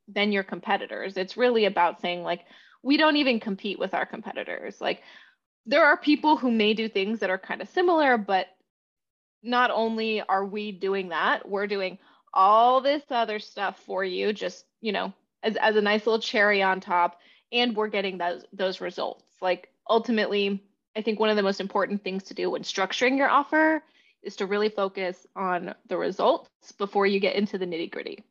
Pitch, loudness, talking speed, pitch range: 205 Hz, -25 LUFS, 190 wpm, 195-240 Hz